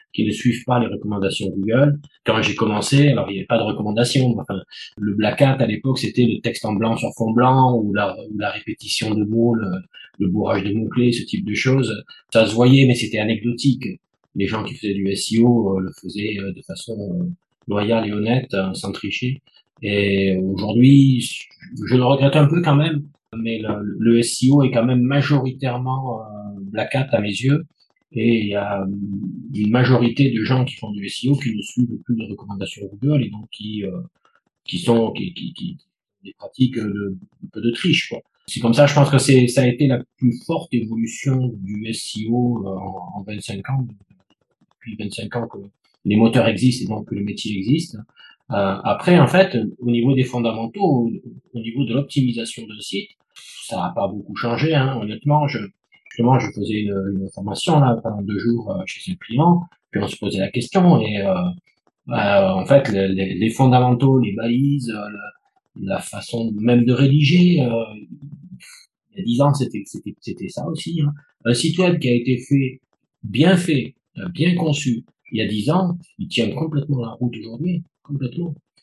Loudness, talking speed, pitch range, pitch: -19 LUFS, 195 wpm, 105-140 Hz, 120 Hz